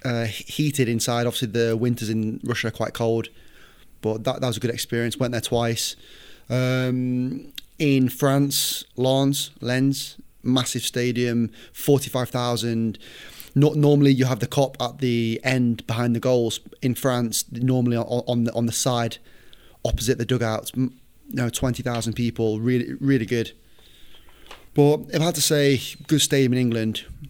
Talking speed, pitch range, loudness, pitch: 160 wpm, 115-130 Hz, -23 LUFS, 125 Hz